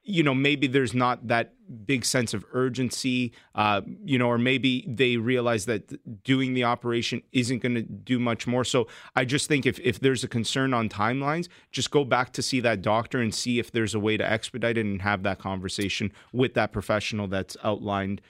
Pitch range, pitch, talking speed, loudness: 110-130 Hz, 120 Hz, 205 wpm, -26 LUFS